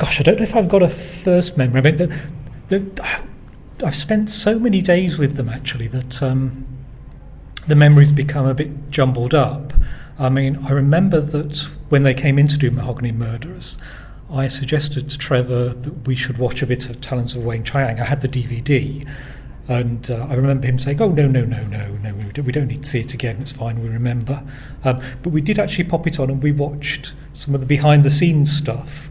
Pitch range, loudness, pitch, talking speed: 130-150 Hz, -18 LUFS, 140 Hz, 205 wpm